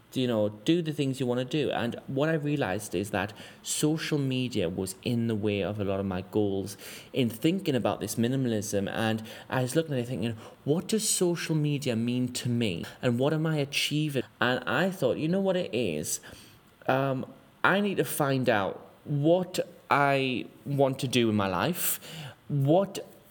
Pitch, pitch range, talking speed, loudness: 130 Hz, 110-150 Hz, 195 wpm, -28 LUFS